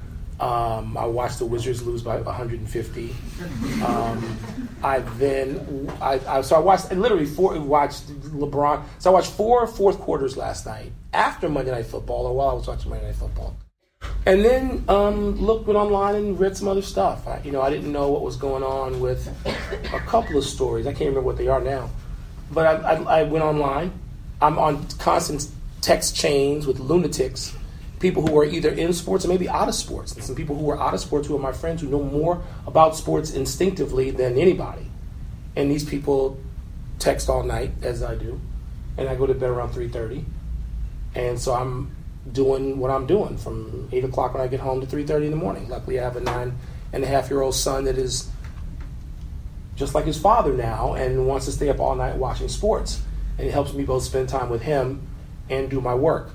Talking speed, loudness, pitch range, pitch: 205 wpm, -23 LUFS, 125-150 Hz, 135 Hz